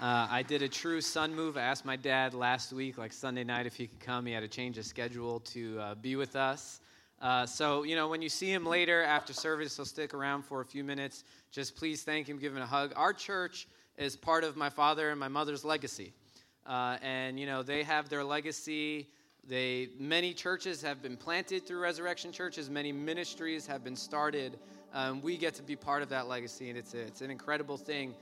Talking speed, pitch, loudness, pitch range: 225 wpm, 140 Hz, -35 LUFS, 130-155 Hz